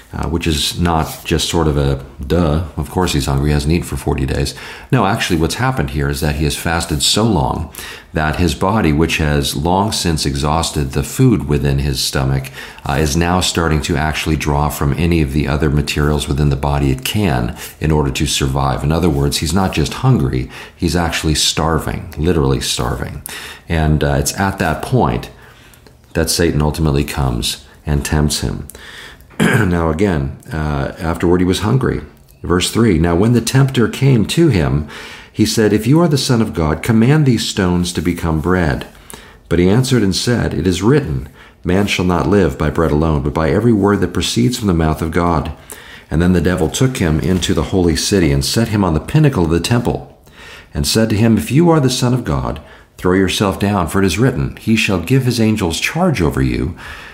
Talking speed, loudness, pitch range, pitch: 205 wpm, -15 LUFS, 75-100 Hz, 80 Hz